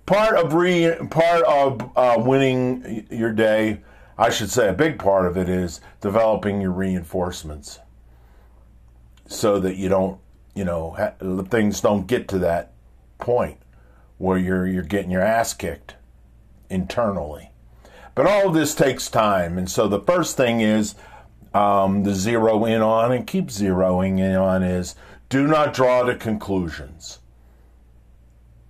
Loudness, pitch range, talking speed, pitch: -20 LUFS, 85-115 Hz, 145 wpm, 95 Hz